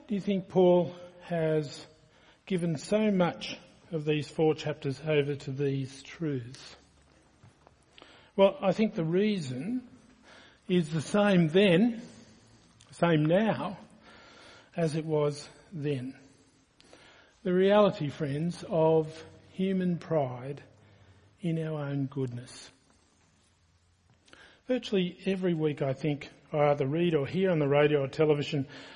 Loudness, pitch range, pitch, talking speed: -29 LUFS, 135-180 Hz, 155 Hz, 115 wpm